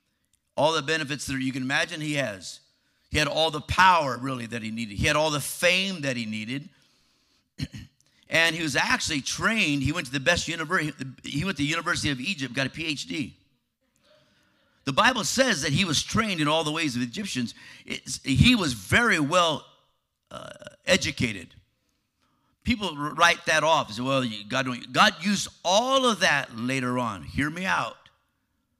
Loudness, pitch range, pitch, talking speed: -24 LUFS, 130-170 Hz, 150 Hz, 180 wpm